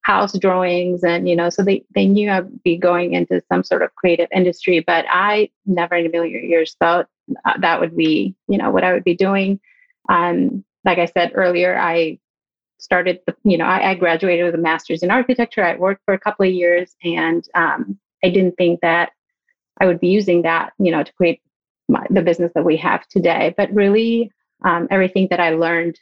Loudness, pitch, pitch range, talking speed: -17 LUFS, 180 Hz, 170-195 Hz, 210 wpm